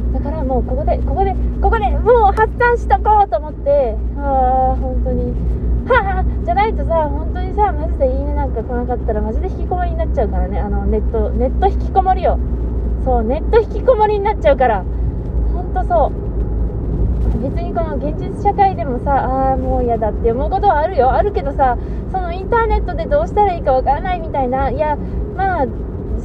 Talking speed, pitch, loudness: 395 characters per minute, 280 Hz, -17 LUFS